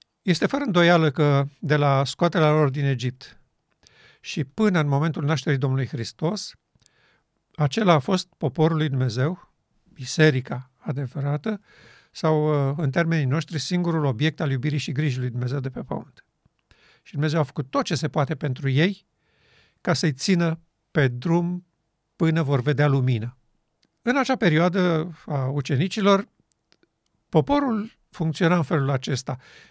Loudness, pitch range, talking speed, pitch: -23 LUFS, 140-170 Hz, 140 wpm, 155 Hz